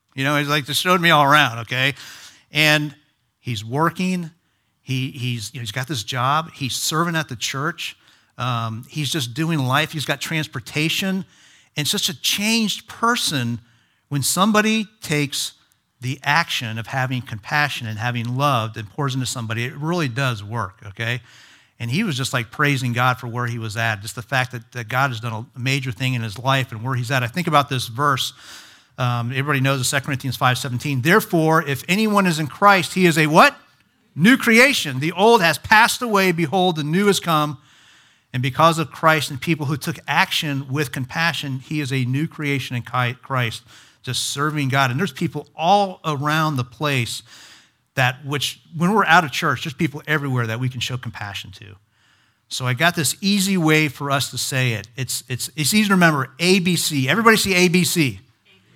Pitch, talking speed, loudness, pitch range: 140 Hz, 195 wpm, -19 LUFS, 125-165 Hz